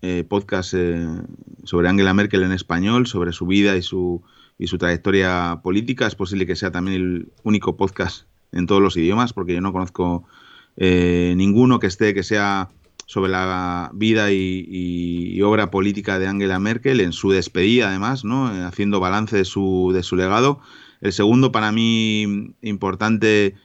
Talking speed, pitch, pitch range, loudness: 170 wpm, 95 Hz, 90-105 Hz, -19 LUFS